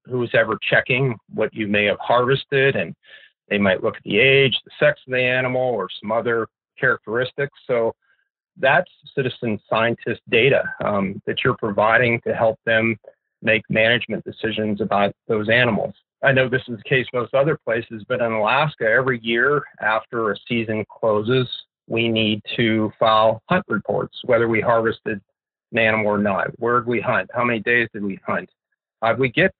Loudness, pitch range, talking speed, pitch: -20 LUFS, 110-130 Hz, 180 wpm, 115 Hz